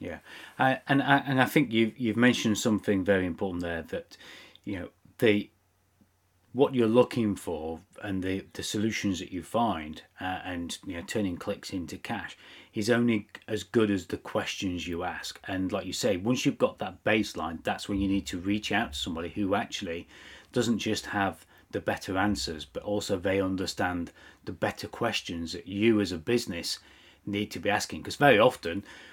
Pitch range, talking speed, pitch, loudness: 95-115 Hz, 185 wpm, 100 Hz, -29 LUFS